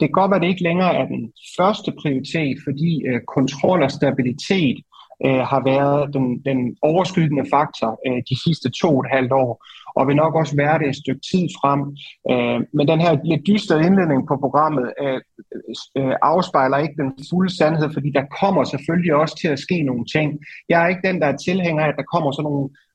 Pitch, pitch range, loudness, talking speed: 145 Hz, 135-165 Hz, -19 LUFS, 210 wpm